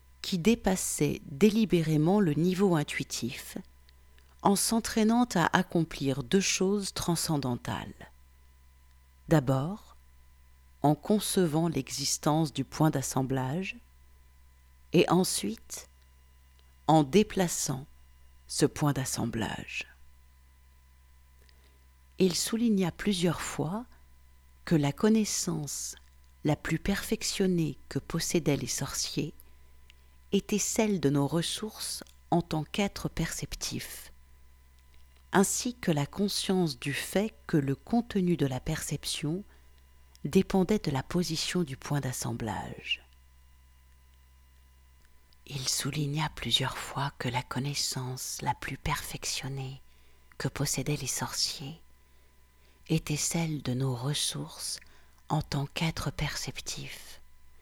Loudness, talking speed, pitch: -30 LUFS, 95 wpm, 135 Hz